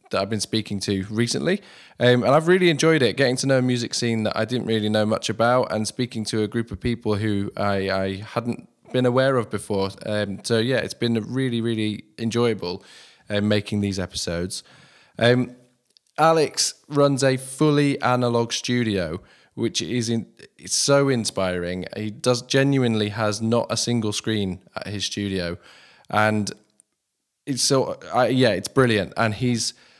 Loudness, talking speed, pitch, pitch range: -22 LUFS, 170 wpm, 115 Hz, 105-125 Hz